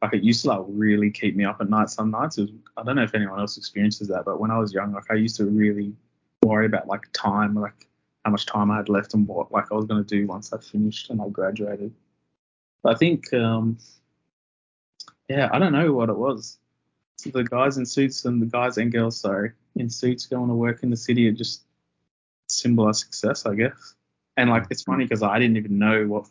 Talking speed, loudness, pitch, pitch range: 240 wpm, -23 LUFS, 110 Hz, 100-115 Hz